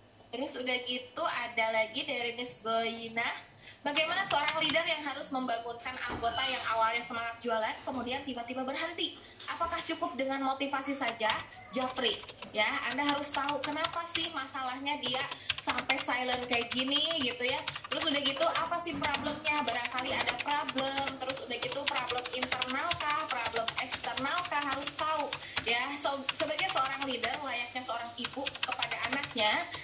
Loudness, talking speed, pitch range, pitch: -30 LUFS, 145 wpm, 245-295 Hz, 270 Hz